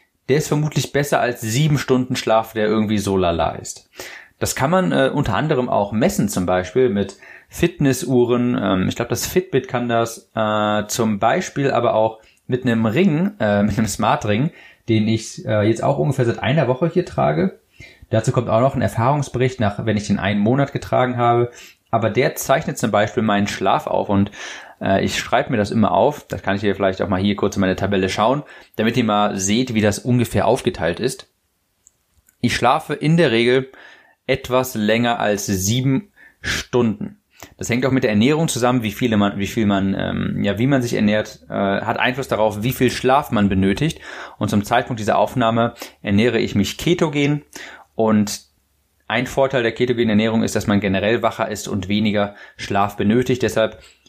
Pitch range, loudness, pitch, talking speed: 105-130 Hz, -19 LUFS, 115 Hz, 190 wpm